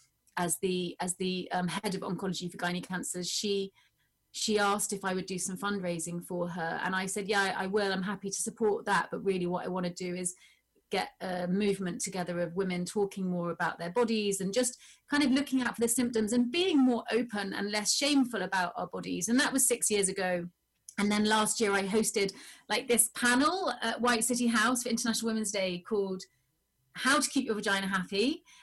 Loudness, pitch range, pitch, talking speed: -30 LUFS, 180-230 Hz, 200 Hz, 215 wpm